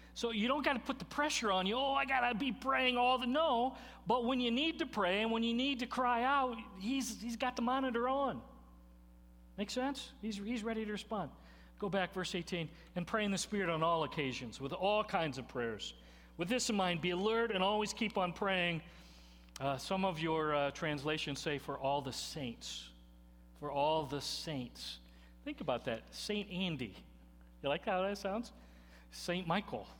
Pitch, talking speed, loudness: 185 Hz, 200 wpm, -36 LUFS